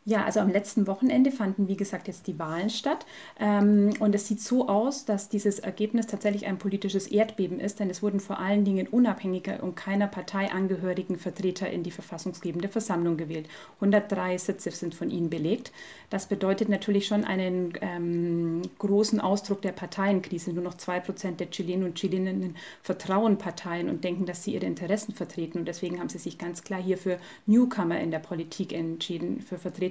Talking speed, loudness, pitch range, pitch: 185 wpm, -28 LUFS, 180-205 Hz, 190 Hz